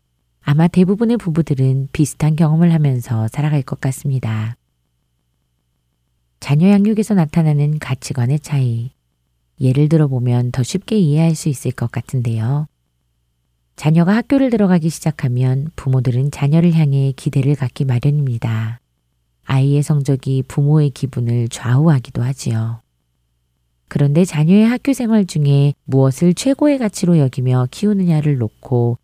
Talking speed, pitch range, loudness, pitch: 305 characters per minute, 120-160 Hz, -16 LUFS, 140 Hz